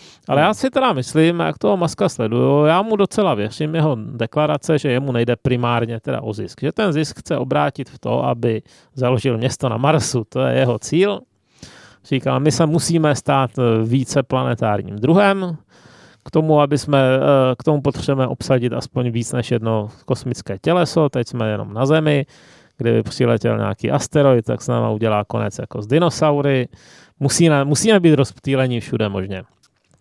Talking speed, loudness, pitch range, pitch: 165 wpm, -18 LUFS, 120-155 Hz, 130 Hz